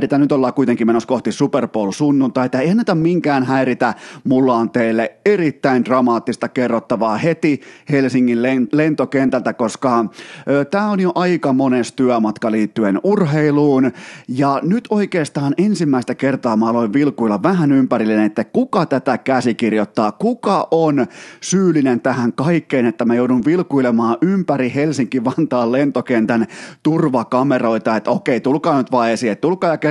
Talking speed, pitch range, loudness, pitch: 135 wpm, 120-155 Hz, -16 LUFS, 130 Hz